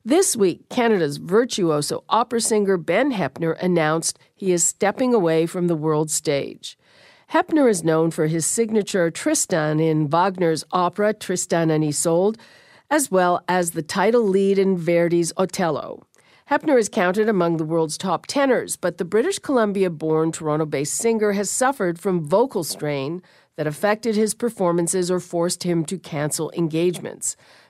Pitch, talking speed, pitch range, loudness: 180 Hz, 145 wpm, 165-215 Hz, -21 LUFS